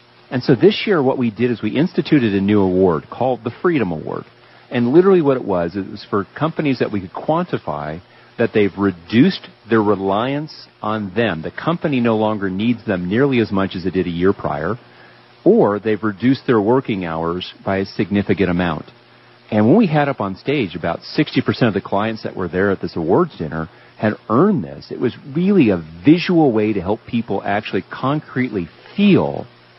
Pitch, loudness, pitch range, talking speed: 110 Hz, -18 LUFS, 95-130 Hz, 195 wpm